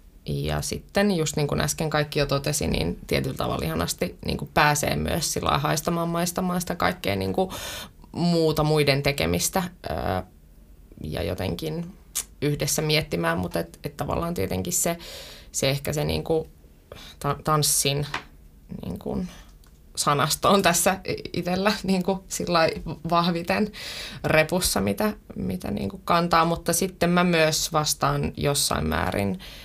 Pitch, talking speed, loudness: 150 Hz, 130 wpm, -24 LUFS